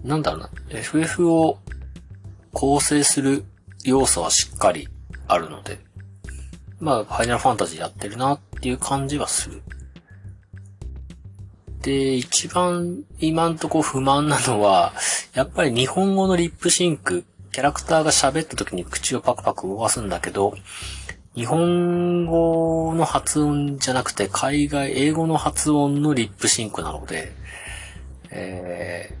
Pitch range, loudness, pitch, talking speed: 95-150 Hz, -21 LUFS, 130 Hz, 270 characters per minute